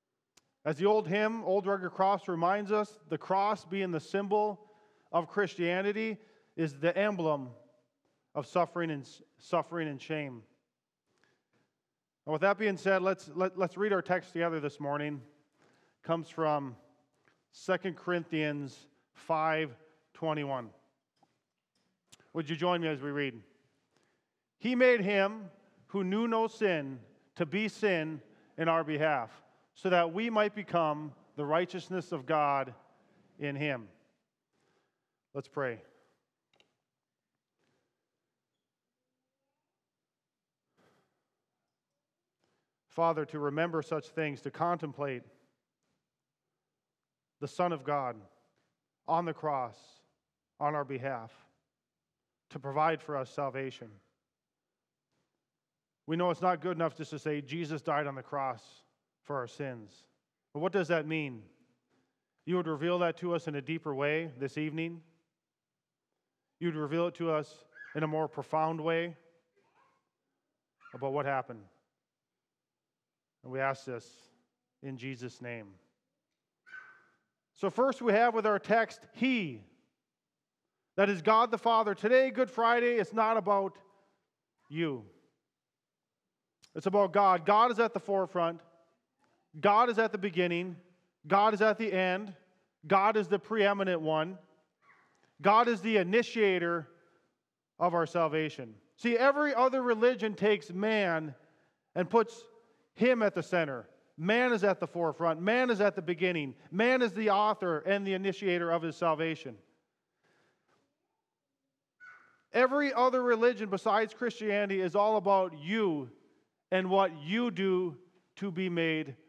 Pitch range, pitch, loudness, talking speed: 150-200 Hz, 170 Hz, -31 LUFS, 125 wpm